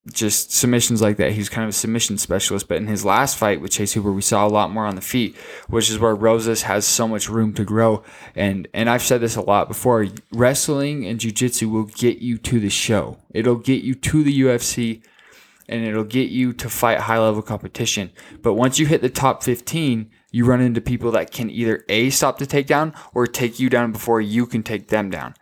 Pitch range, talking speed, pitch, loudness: 105-125 Hz, 225 wpm, 115 Hz, -19 LUFS